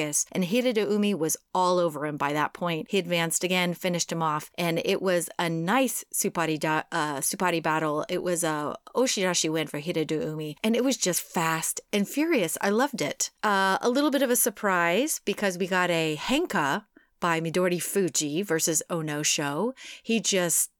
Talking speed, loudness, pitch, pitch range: 185 wpm, -26 LUFS, 175 Hz, 160-200 Hz